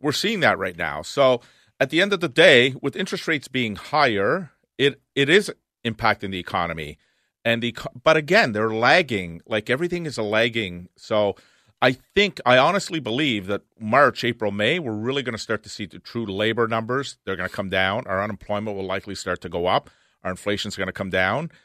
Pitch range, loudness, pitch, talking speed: 100-130 Hz, -22 LUFS, 110 Hz, 210 wpm